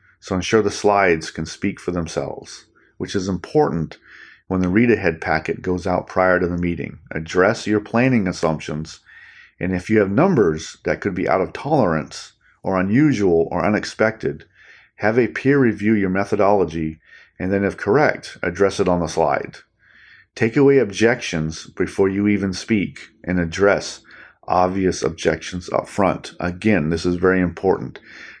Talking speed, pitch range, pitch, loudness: 155 wpm, 85-105 Hz, 95 Hz, -20 LUFS